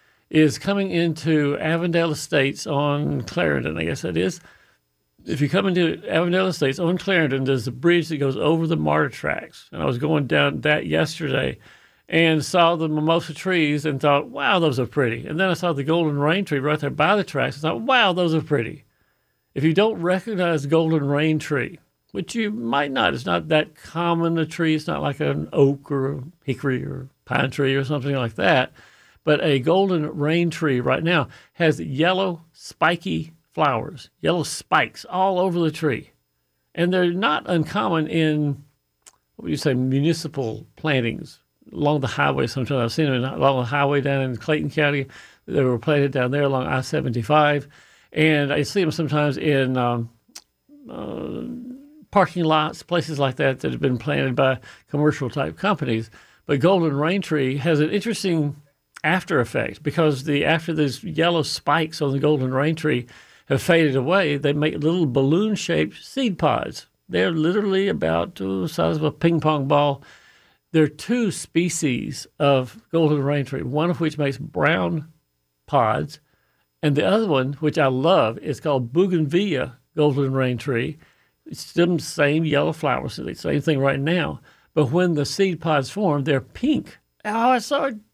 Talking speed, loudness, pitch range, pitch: 175 wpm, -21 LUFS, 140-170 Hz, 150 Hz